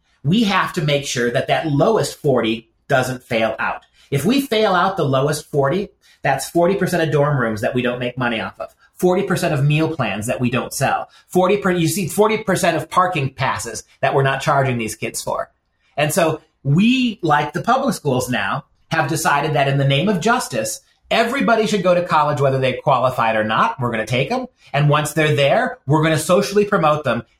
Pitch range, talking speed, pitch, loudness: 130-185 Hz, 210 wpm, 150 Hz, -18 LUFS